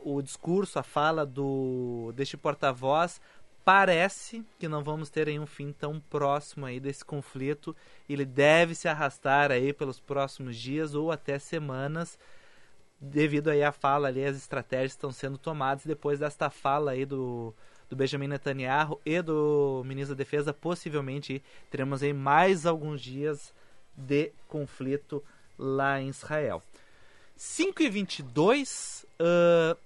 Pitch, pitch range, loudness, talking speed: 145 Hz, 135-155 Hz, -29 LUFS, 135 wpm